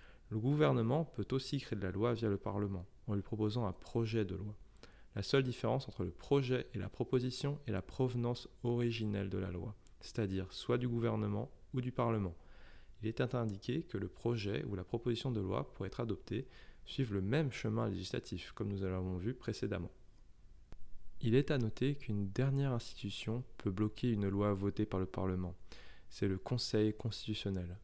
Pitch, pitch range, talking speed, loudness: 110 Hz, 100-125 Hz, 180 wpm, -38 LUFS